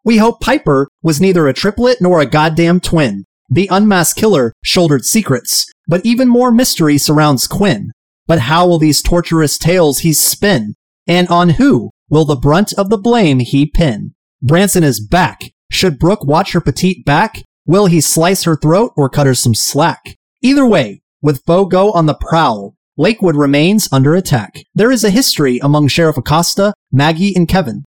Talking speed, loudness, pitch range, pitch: 175 wpm, -11 LUFS, 150-195 Hz, 170 Hz